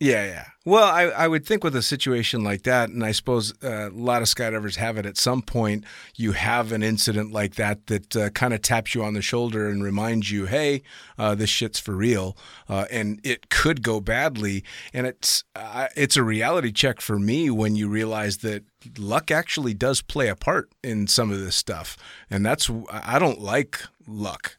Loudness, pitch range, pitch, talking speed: -23 LUFS, 105-125 Hz, 110 Hz, 205 wpm